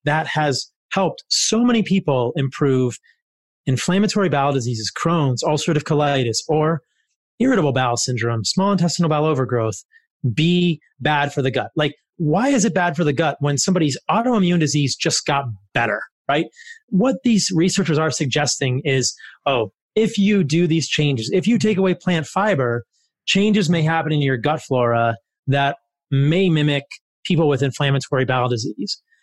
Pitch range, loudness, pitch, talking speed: 135-180 Hz, -19 LUFS, 150 Hz, 155 wpm